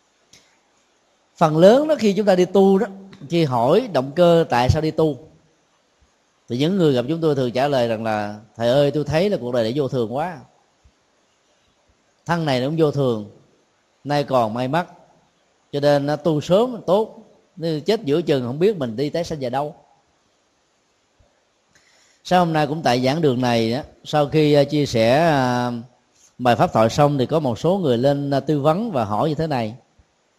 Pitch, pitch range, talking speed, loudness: 150 Hz, 125-170 Hz, 190 wpm, -19 LUFS